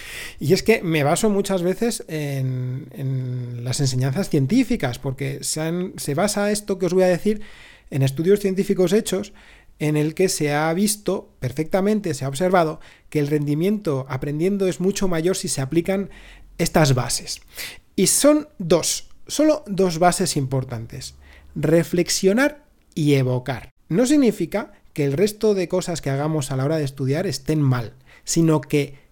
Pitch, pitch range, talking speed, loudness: 170 Hz, 140-195 Hz, 160 wpm, -21 LUFS